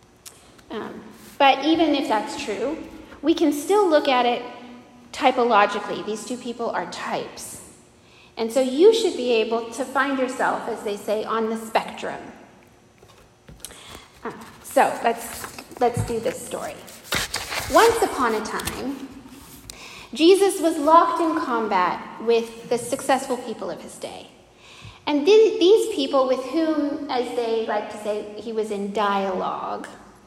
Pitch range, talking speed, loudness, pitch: 225-295 Hz, 140 wpm, -22 LUFS, 250 Hz